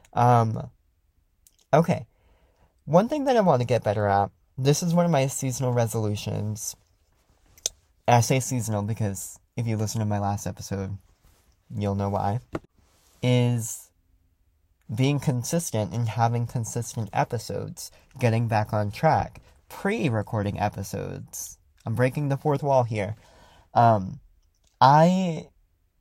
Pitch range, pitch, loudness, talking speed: 95-125 Hz, 110 Hz, -25 LUFS, 125 wpm